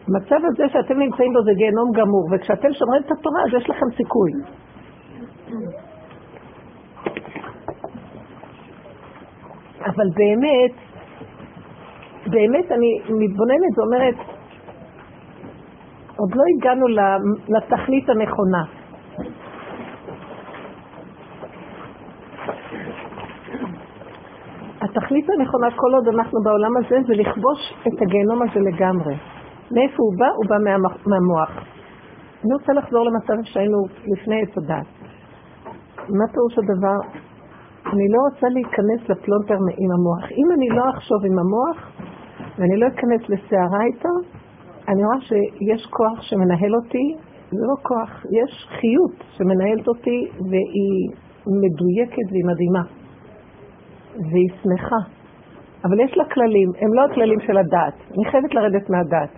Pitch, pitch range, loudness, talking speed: 220 Hz, 195-250 Hz, -19 LUFS, 110 wpm